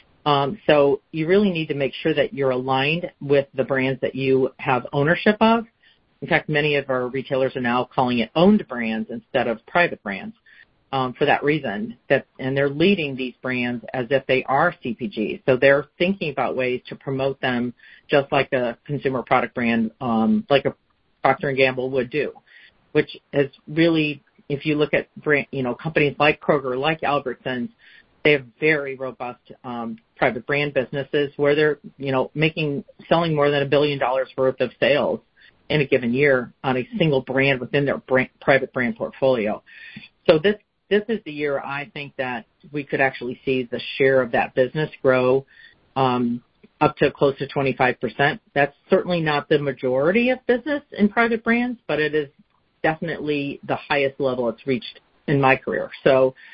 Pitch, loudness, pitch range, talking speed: 140 Hz, -21 LUFS, 130-150 Hz, 185 wpm